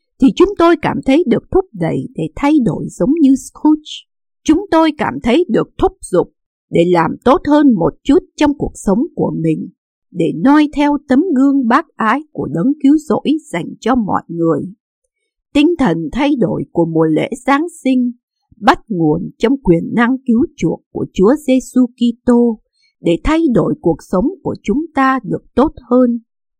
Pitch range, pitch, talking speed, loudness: 230-300 Hz, 265 Hz, 175 wpm, -14 LUFS